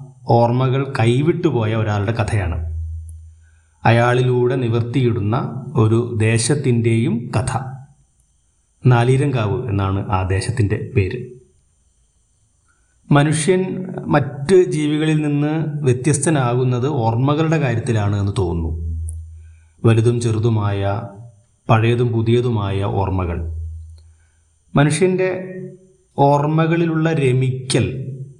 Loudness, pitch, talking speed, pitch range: -18 LUFS, 120 Hz, 65 wpm, 100-135 Hz